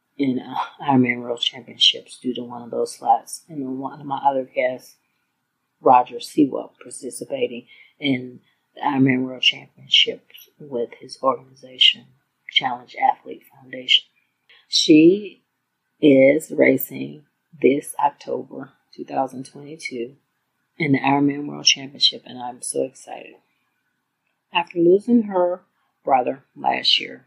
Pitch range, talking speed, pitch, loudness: 125-180 Hz, 110 wpm, 135 Hz, -20 LUFS